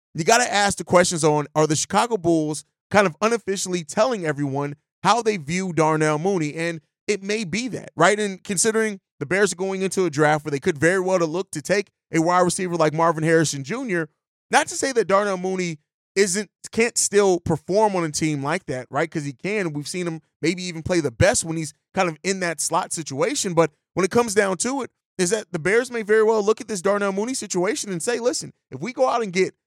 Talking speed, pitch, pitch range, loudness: 235 wpm, 180 Hz, 160-210 Hz, -22 LUFS